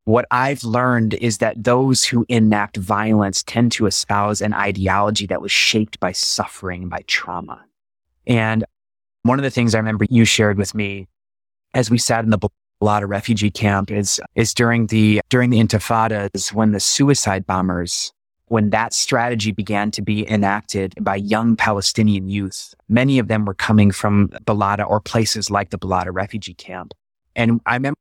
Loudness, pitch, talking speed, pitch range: -18 LUFS, 105 Hz, 170 wpm, 100-115 Hz